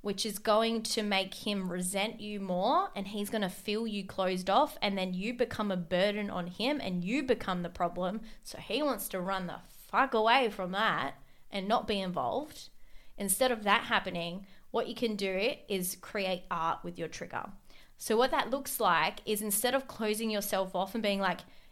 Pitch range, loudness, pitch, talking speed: 185-225 Hz, -32 LUFS, 205 Hz, 195 wpm